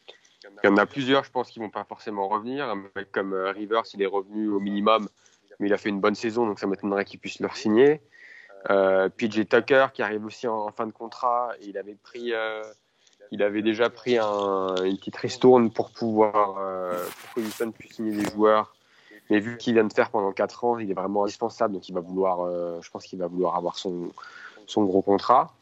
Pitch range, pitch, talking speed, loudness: 100-115 Hz, 105 Hz, 230 wpm, -25 LUFS